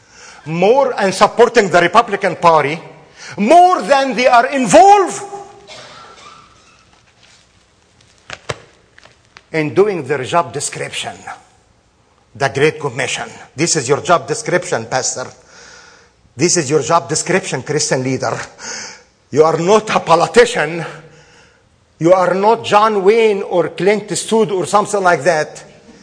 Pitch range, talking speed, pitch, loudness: 155-220 Hz, 115 wpm, 175 Hz, -13 LUFS